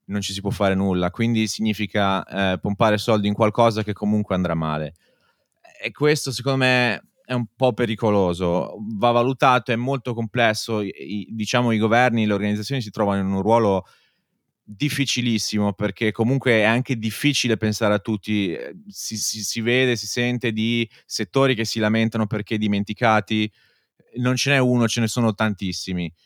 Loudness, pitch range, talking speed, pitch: -21 LUFS, 105-120 Hz, 165 wpm, 110 Hz